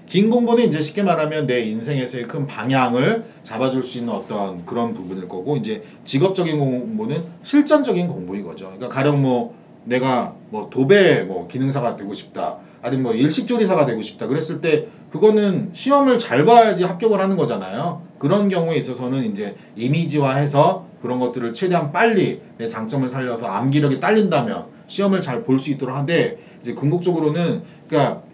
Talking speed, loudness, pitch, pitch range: 370 characters per minute, -19 LUFS, 150 Hz, 125-195 Hz